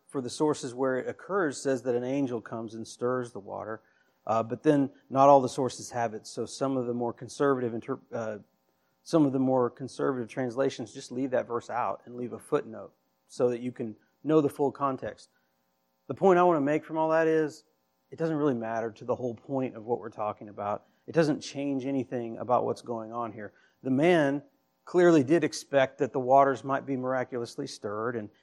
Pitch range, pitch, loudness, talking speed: 115-140 Hz, 125 Hz, -29 LUFS, 210 wpm